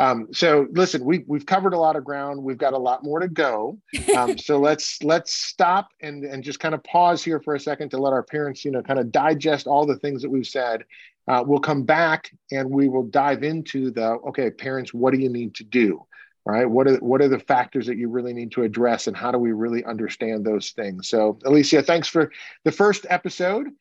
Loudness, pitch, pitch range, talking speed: -22 LUFS, 140 Hz, 125-155 Hz, 235 wpm